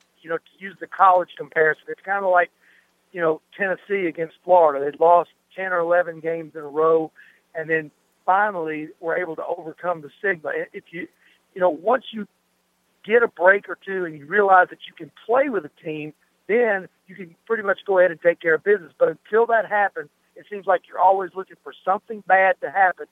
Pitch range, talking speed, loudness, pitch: 165-195 Hz, 215 wpm, -21 LUFS, 180 Hz